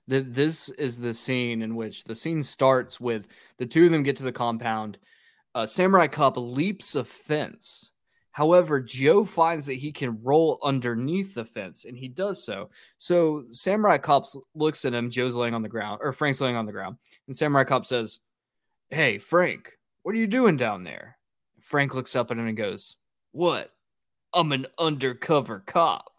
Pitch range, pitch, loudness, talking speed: 120-160 Hz, 135 Hz, -25 LUFS, 180 wpm